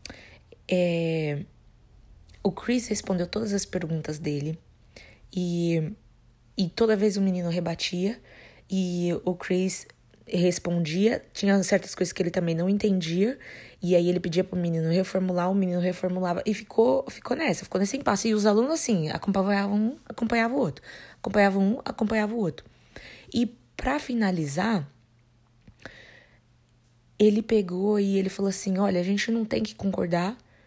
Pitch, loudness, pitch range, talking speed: 185 Hz, -26 LUFS, 170-210 Hz, 145 wpm